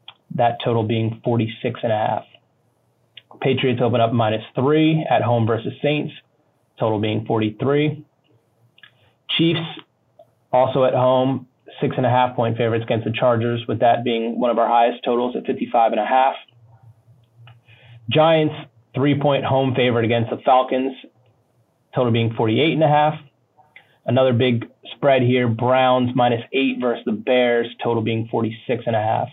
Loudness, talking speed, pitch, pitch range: -19 LUFS, 155 wpm, 125 Hz, 115-135 Hz